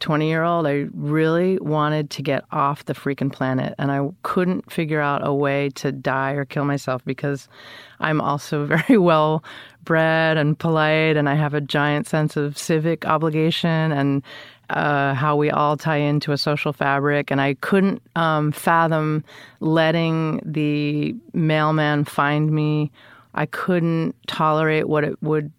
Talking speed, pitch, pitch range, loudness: 155 wpm, 150 Hz, 145-160 Hz, -21 LUFS